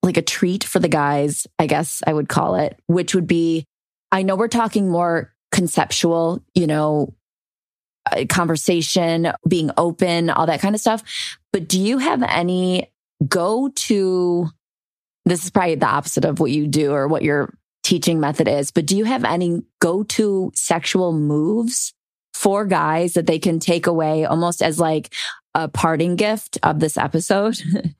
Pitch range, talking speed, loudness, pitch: 160-190 Hz, 165 wpm, -19 LUFS, 175 Hz